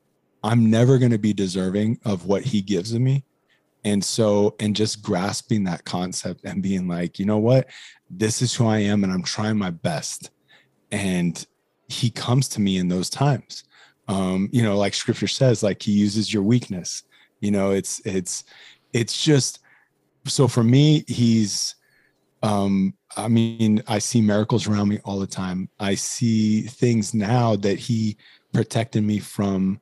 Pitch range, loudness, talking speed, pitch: 100-115 Hz, -22 LUFS, 170 wpm, 105 Hz